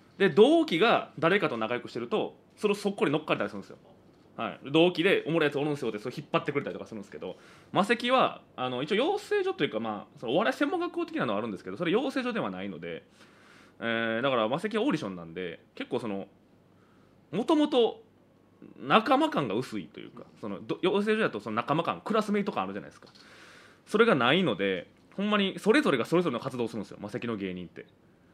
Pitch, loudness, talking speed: 175 Hz, -28 LUFS, 470 characters per minute